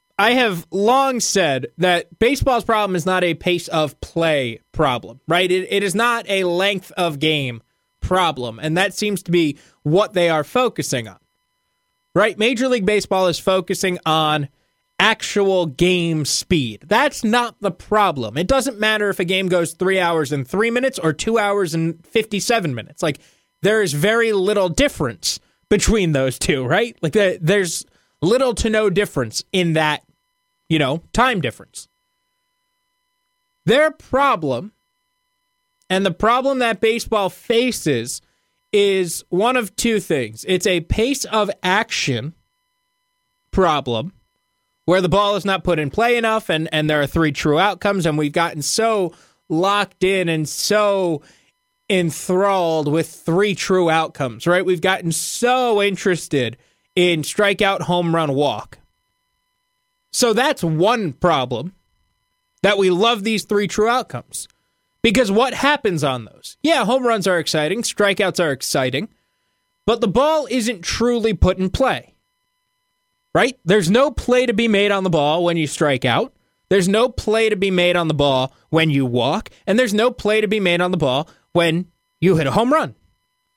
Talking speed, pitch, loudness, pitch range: 160 wpm, 190 Hz, -18 LUFS, 165-230 Hz